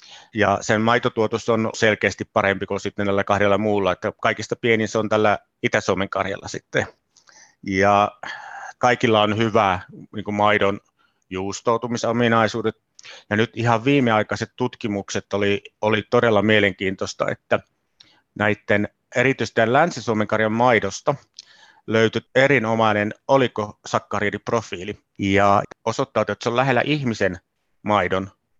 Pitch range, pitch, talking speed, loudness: 100-115 Hz, 110 Hz, 115 wpm, -21 LUFS